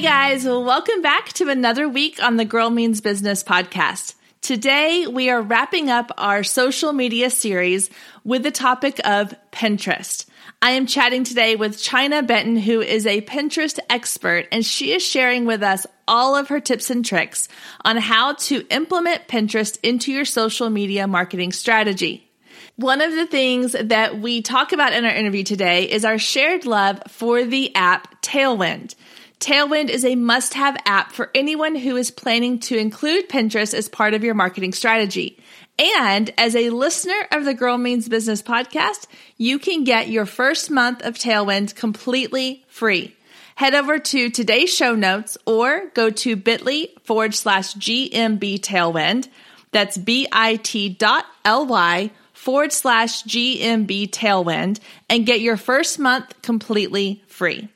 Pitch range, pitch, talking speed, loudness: 215-265 Hz, 235 Hz, 155 wpm, -18 LUFS